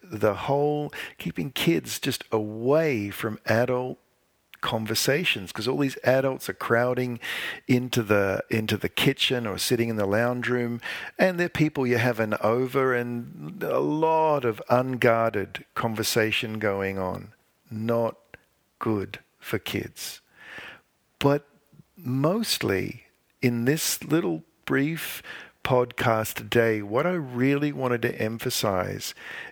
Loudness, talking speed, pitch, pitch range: -26 LUFS, 120 wpm, 125 Hz, 110-140 Hz